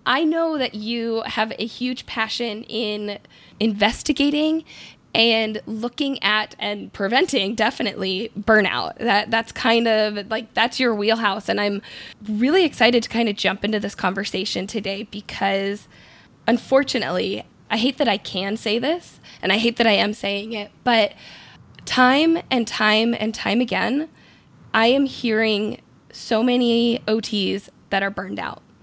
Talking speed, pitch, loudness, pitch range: 150 wpm, 225 Hz, -21 LUFS, 205-240 Hz